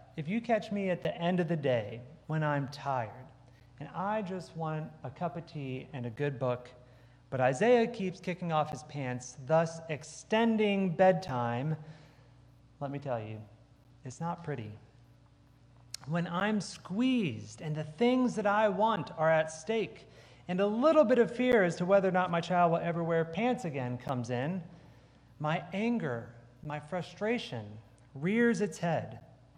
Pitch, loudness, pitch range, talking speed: 155 Hz, -32 LUFS, 125-185 Hz, 165 wpm